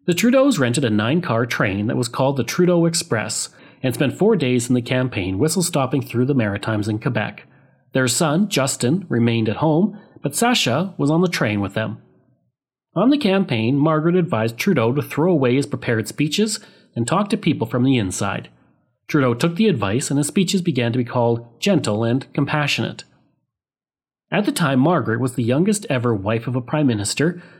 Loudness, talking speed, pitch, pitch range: -19 LUFS, 190 wpm, 135 Hz, 115-170 Hz